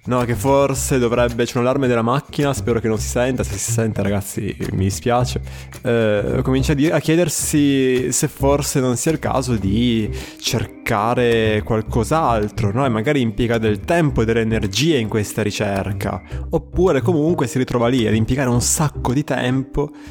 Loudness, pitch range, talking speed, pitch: -18 LUFS, 110-135 Hz, 175 wpm, 120 Hz